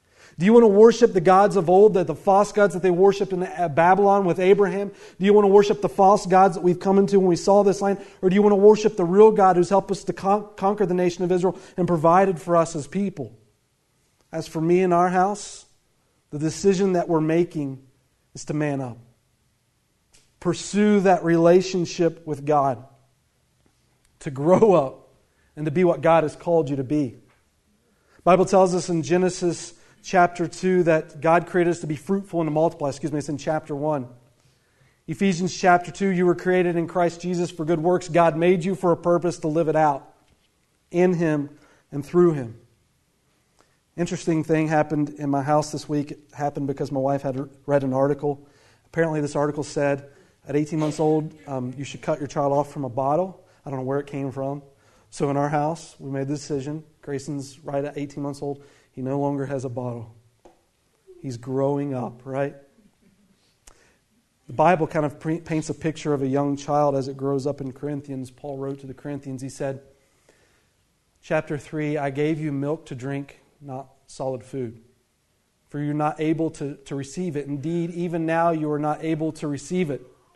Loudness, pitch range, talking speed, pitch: -22 LUFS, 140-180 Hz, 200 wpm, 155 Hz